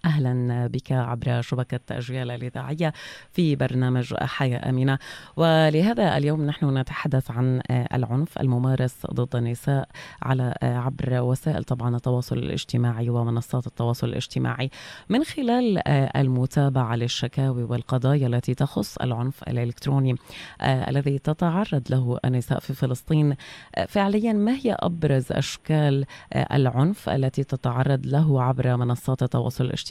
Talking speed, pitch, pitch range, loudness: 110 wpm, 130 Hz, 125-145 Hz, -24 LUFS